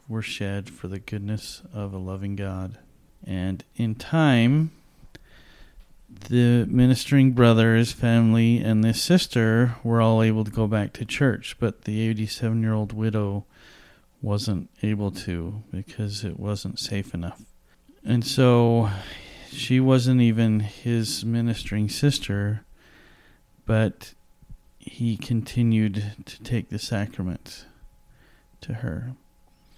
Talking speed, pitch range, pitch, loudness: 115 wpm, 100-120 Hz, 110 Hz, -23 LUFS